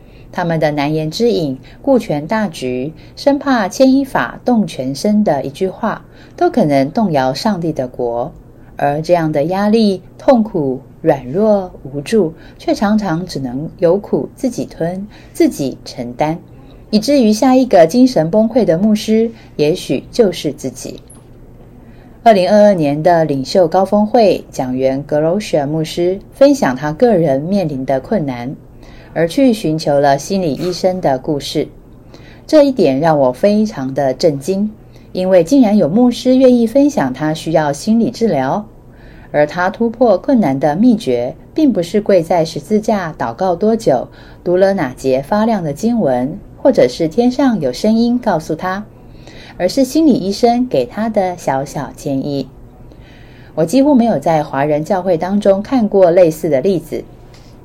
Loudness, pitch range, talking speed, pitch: -14 LUFS, 145-220 Hz, 225 characters per minute, 180 Hz